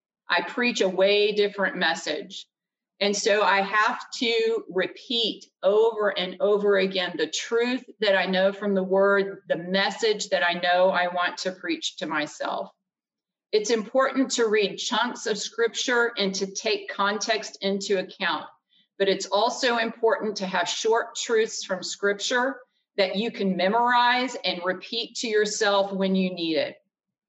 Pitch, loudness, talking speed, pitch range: 200 Hz, -24 LUFS, 155 wpm, 190-230 Hz